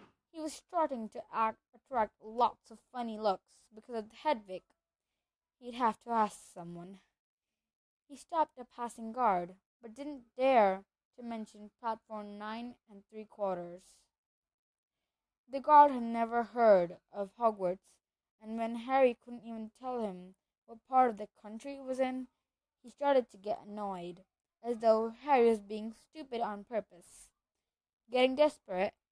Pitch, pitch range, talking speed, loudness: 225 Hz, 210-250 Hz, 145 wpm, -33 LUFS